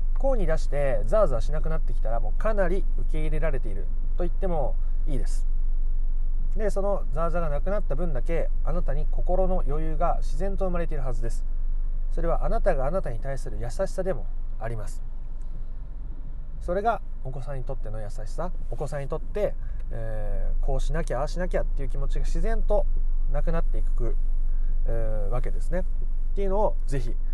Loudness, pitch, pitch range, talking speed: -30 LUFS, 135 Hz, 120-170 Hz, 380 characters per minute